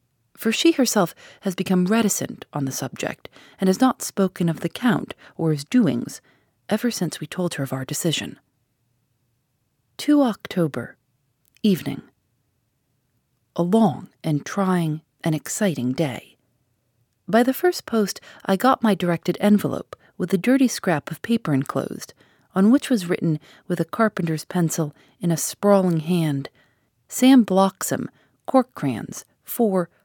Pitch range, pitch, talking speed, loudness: 135-210 Hz, 170 Hz, 140 wpm, -22 LUFS